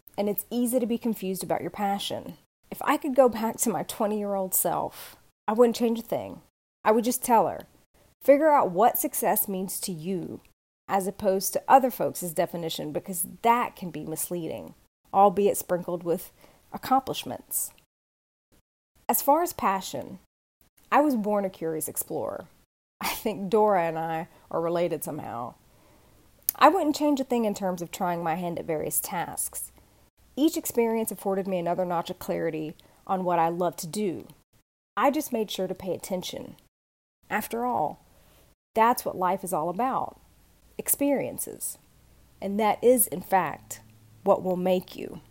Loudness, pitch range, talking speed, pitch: -26 LUFS, 175-235 Hz, 165 wpm, 195 Hz